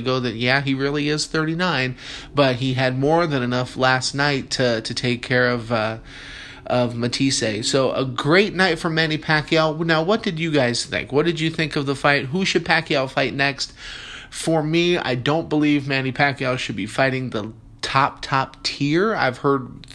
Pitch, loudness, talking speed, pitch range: 135 Hz, -20 LUFS, 195 wpm, 130-155 Hz